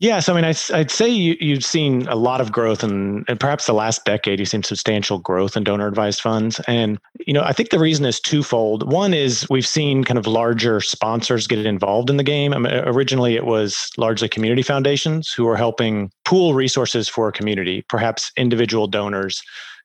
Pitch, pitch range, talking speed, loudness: 115 Hz, 110-140 Hz, 210 wpm, -18 LUFS